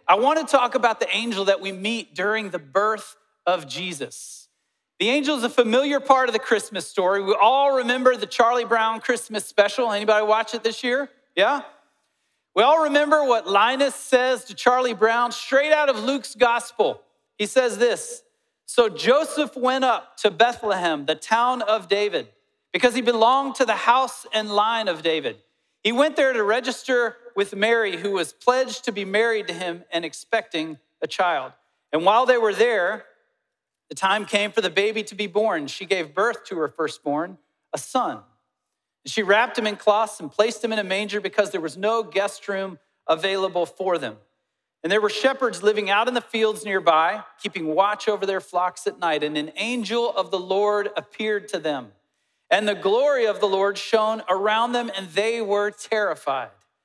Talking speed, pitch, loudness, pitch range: 185 wpm, 215 Hz, -22 LUFS, 195-245 Hz